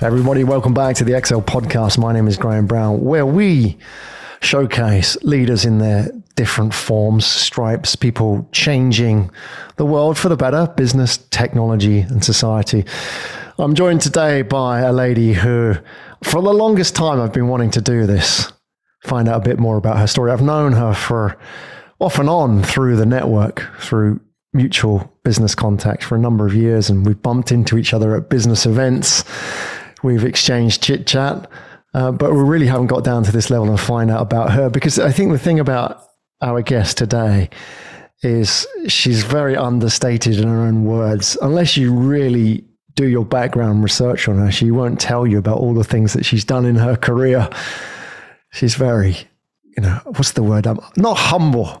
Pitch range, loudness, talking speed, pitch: 110-130 Hz, -15 LUFS, 175 wpm, 120 Hz